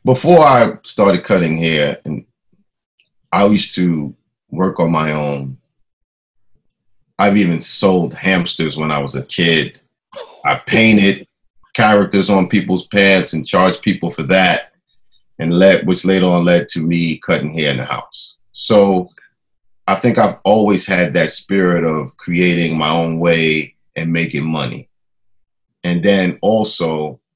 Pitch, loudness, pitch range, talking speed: 85 Hz, -14 LUFS, 80-95 Hz, 145 wpm